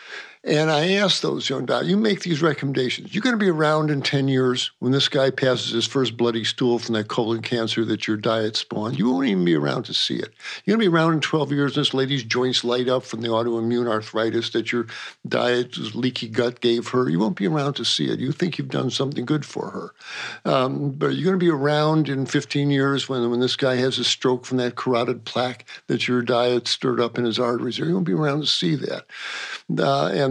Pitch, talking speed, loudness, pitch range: 130 Hz, 240 wpm, -22 LUFS, 120-145 Hz